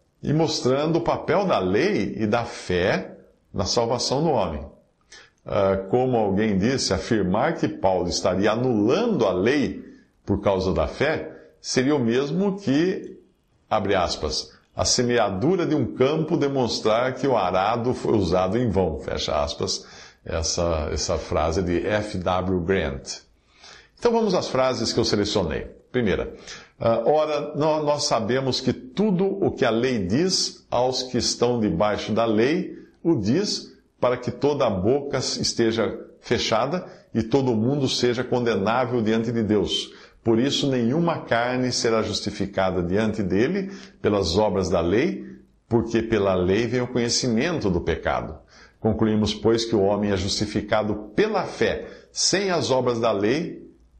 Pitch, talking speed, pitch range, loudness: 115 Hz, 145 wpm, 105-130 Hz, -23 LUFS